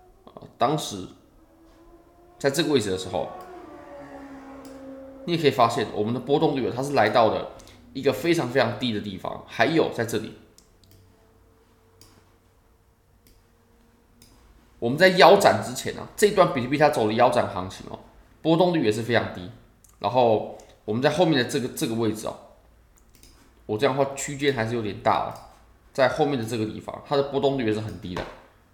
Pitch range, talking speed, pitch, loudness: 110-155 Hz, 255 characters per minute, 120 Hz, -23 LUFS